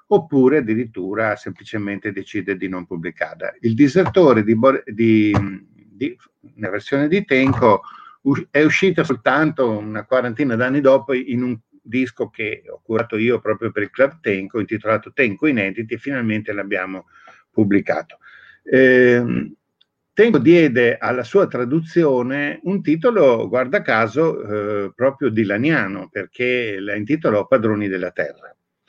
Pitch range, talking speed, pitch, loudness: 105-140 Hz, 130 wpm, 125 Hz, -18 LUFS